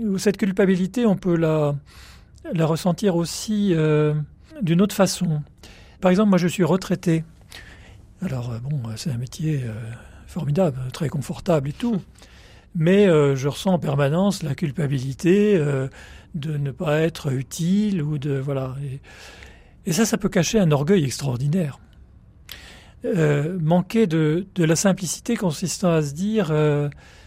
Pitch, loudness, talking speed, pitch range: 160 Hz, -22 LUFS, 145 wpm, 135-185 Hz